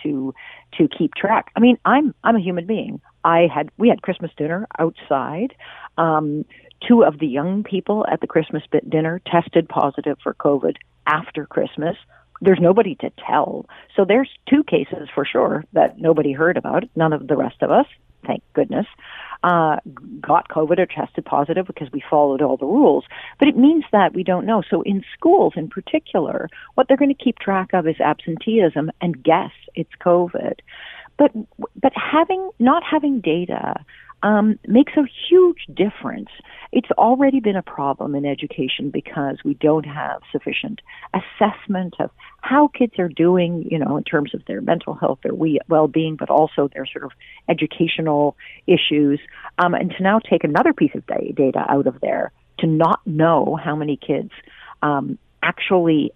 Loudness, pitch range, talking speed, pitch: -19 LUFS, 155-230 Hz, 170 wpm, 175 Hz